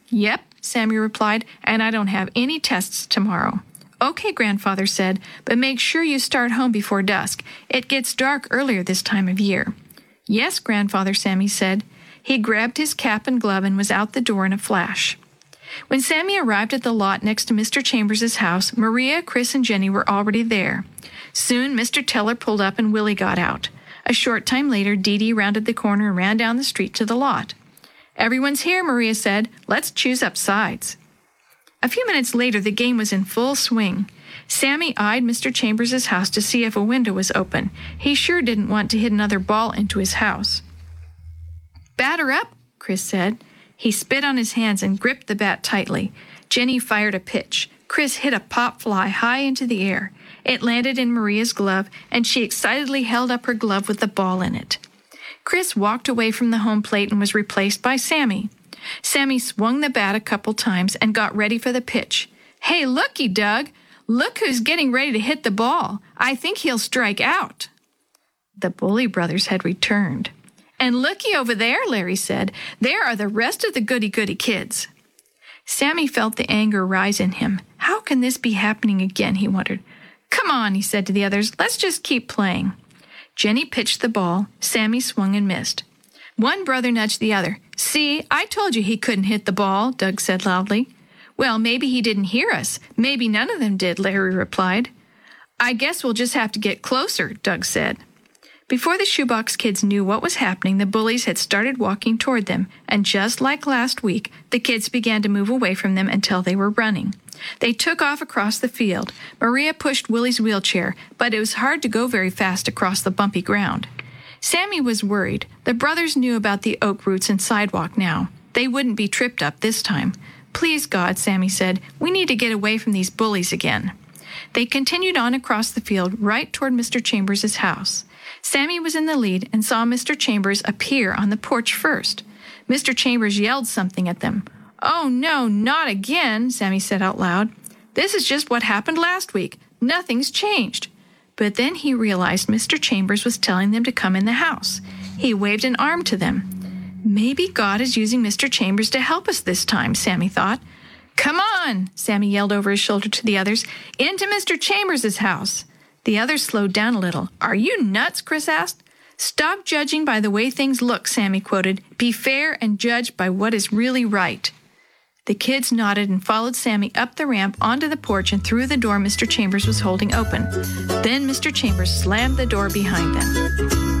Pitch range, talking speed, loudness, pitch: 200-255 Hz, 190 wpm, -20 LUFS, 220 Hz